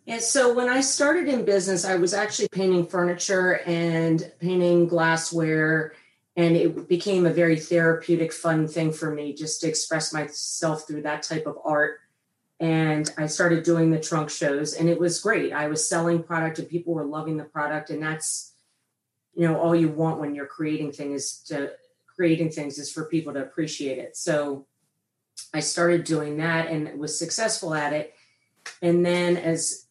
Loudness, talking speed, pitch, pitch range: -24 LUFS, 175 wpm, 160 Hz, 155-170 Hz